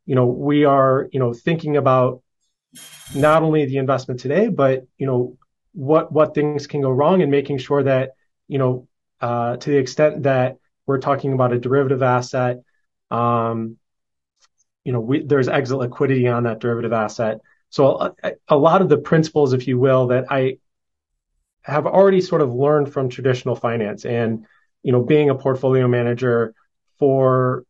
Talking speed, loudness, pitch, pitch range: 170 wpm, -19 LUFS, 130 Hz, 125-140 Hz